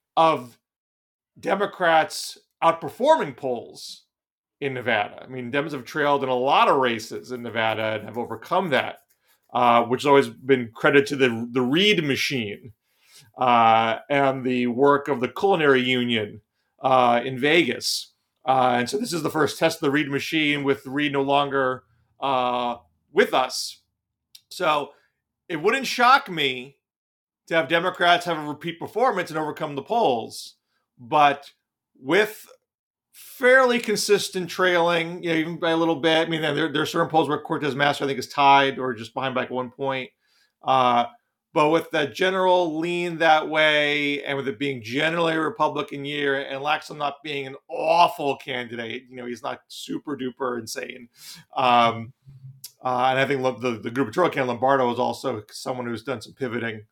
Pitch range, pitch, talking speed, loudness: 125-160 Hz, 140 Hz, 170 wpm, -22 LUFS